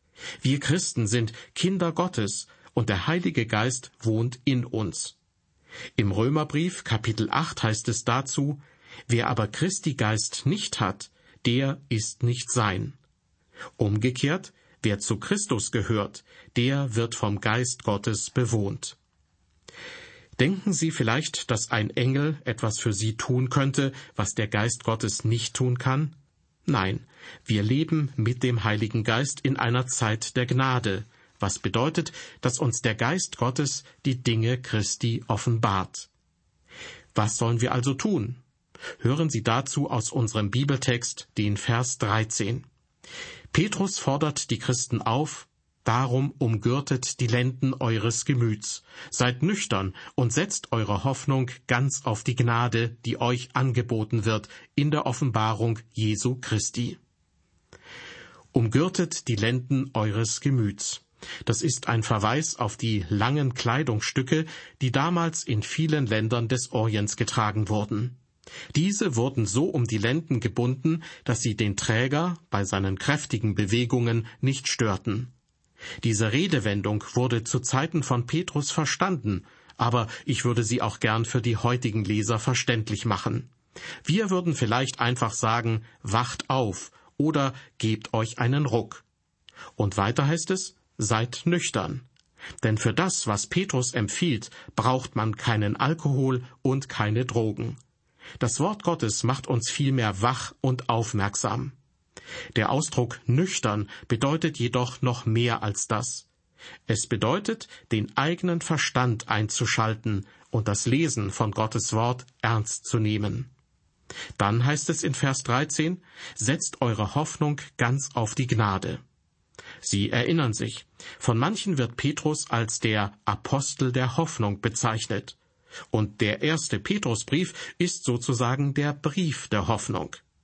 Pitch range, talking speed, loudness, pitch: 110-140 Hz, 130 wpm, -26 LUFS, 120 Hz